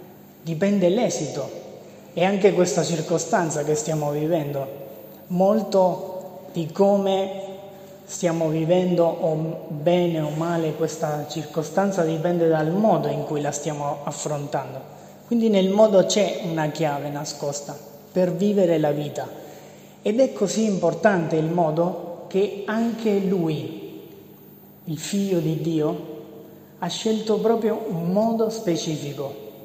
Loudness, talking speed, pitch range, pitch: -23 LUFS, 115 wpm, 155-195 Hz, 170 Hz